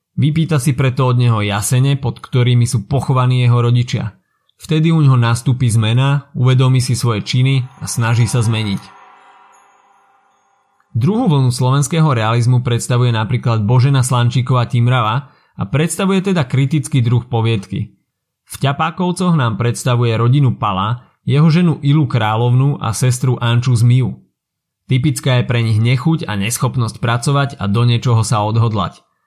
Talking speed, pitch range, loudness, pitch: 135 wpm, 120-140 Hz, -15 LUFS, 125 Hz